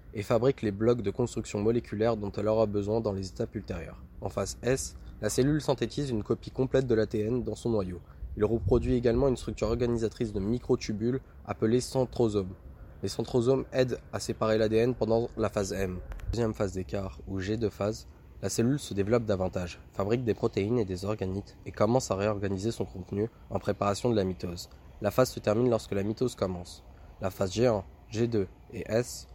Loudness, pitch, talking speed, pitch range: -30 LUFS, 110 Hz, 185 wpm, 95-120 Hz